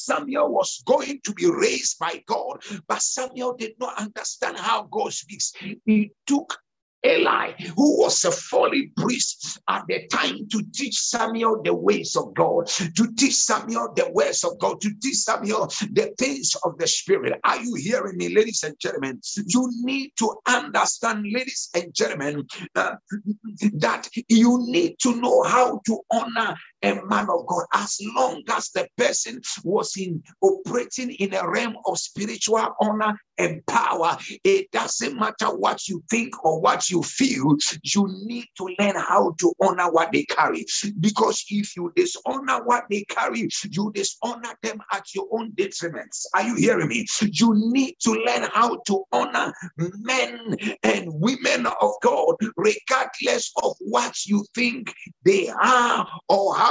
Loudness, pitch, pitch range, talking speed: -23 LUFS, 225 Hz, 205-260 Hz, 160 wpm